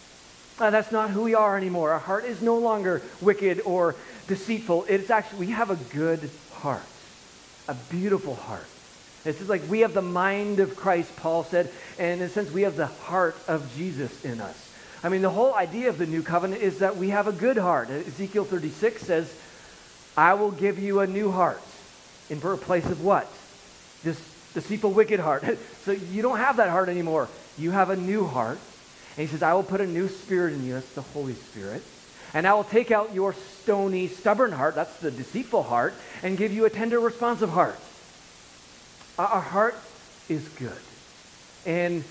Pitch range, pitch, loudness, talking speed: 155-205 Hz, 180 Hz, -26 LUFS, 190 wpm